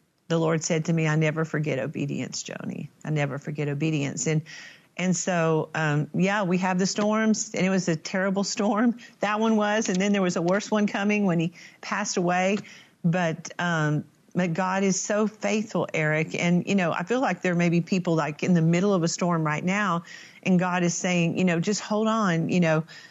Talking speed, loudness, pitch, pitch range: 215 wpm, -25 LUFS, 180 Hz, 165-200 Hz